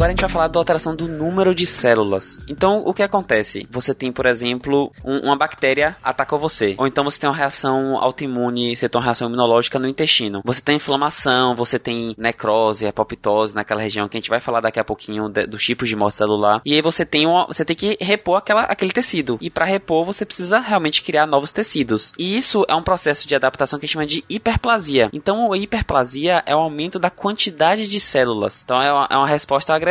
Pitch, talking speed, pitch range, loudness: 140 Hz, 225 wpm, 120-170 Hz, -18 LUFS